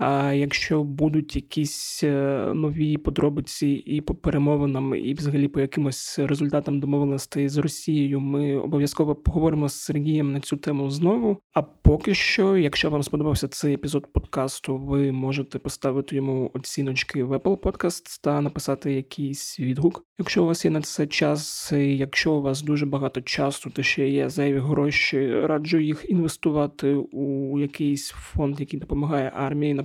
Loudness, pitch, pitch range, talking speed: -24 LUFS, 145 Hz, 140-150 Hz, 150 wpm